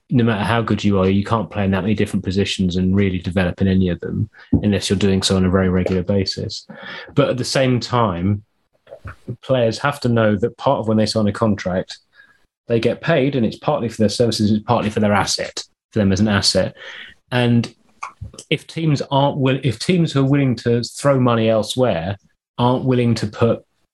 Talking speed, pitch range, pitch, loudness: 210 wpm, 100-125 Hz, 110 Hz, -18 LUFS